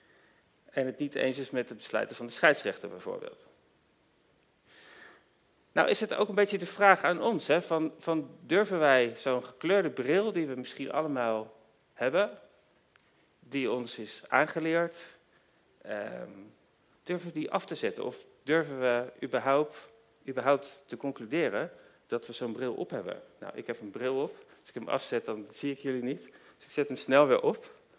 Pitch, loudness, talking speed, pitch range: 150 Hz, -30 LUFS, 175 wpm, 125-195 Hz